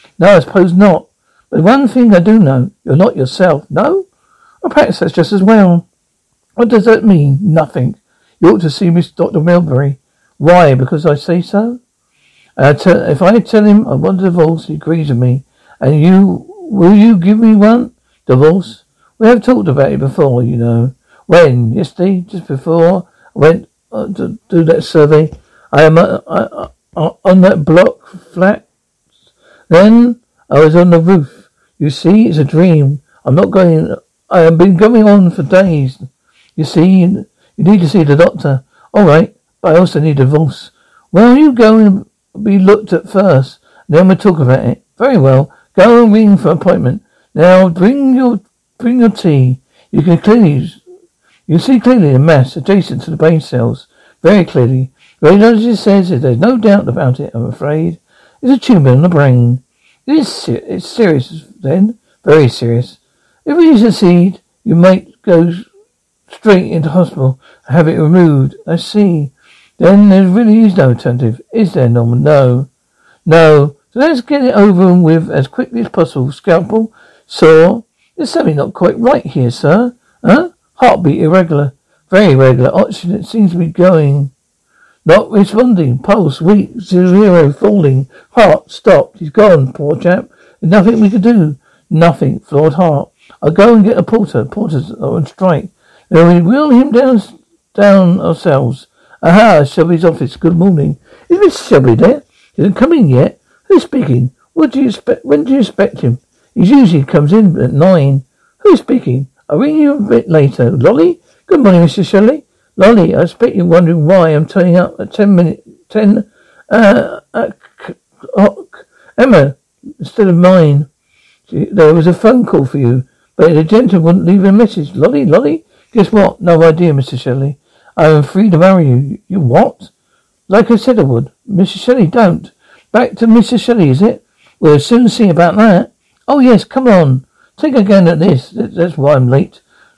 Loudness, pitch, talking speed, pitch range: -9 LUFS, 180 Hz, 175 wpm, 150-215 Hz